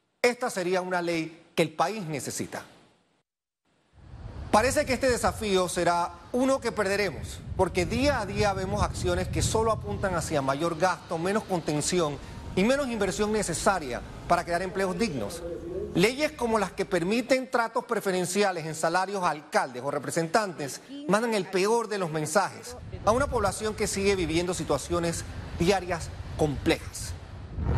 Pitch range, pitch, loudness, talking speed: 165-210 Hz, 185 Hz, -28 LUFS, 145 wpm